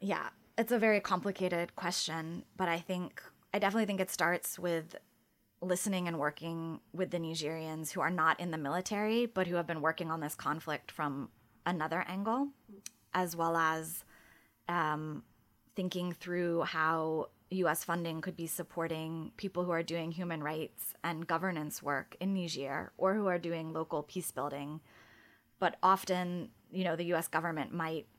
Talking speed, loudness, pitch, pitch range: 160 wpm, -35 LUFS, 170 Hz, 160-185 Hz